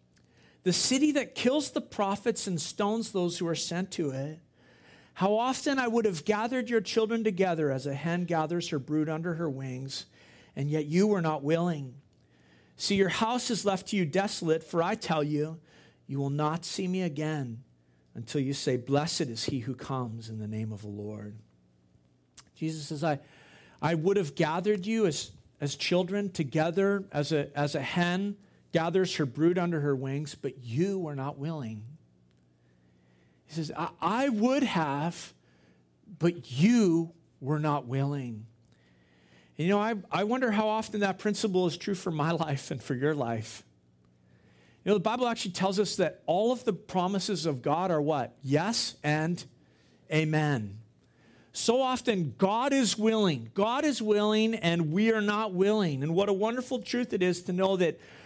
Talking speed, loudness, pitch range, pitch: 175 wpm, -29 LUFS, 135-200 Hz, 165 Hz